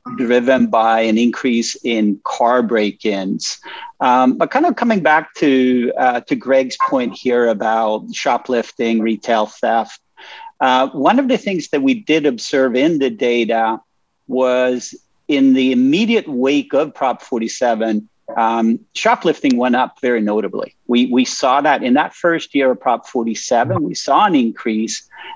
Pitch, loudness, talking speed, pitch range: 125 Hz, -16 LUFS, 155 wpm, 115-150 Hz